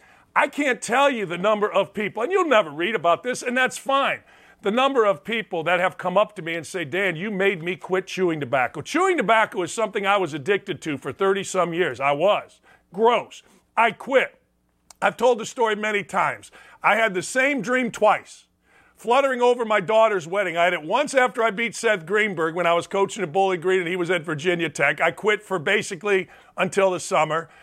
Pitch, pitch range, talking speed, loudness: 200 Hz, 180-225 Hz, 215 wpm, -22 LUFS